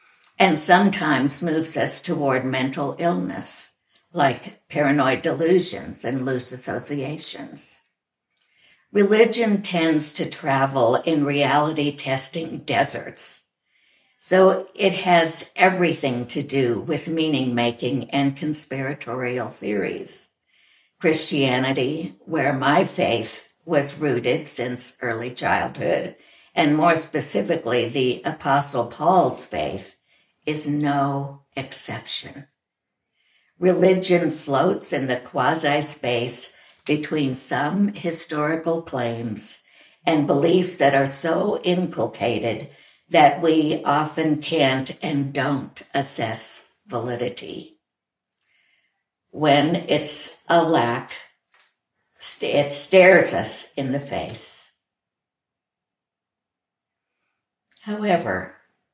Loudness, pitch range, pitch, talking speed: -21 LUFS, 130-165 Hz, 145 Hz, 90 wpm